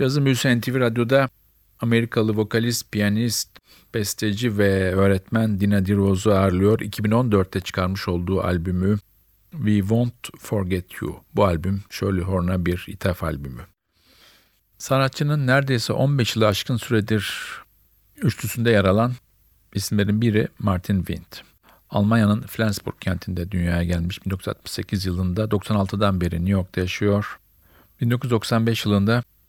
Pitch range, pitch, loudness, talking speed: 95-115 Hz, 105 Hz, -22 LUFS, 110 wpm